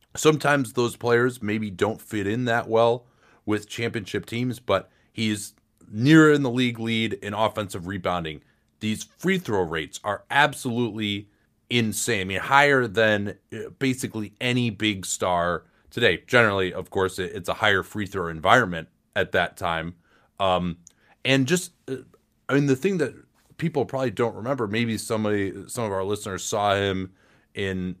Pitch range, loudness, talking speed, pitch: 100-125 Hz, -24 LUFS, 150 wpm, 110 Hz